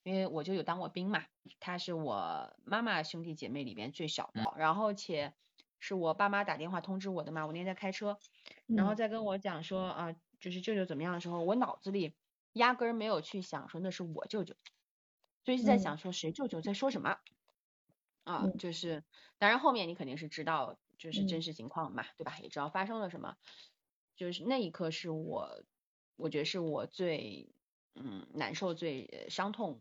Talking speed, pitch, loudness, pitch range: 285 characters per minute, 180 Hz, -37 LUFS, 160-200 Hz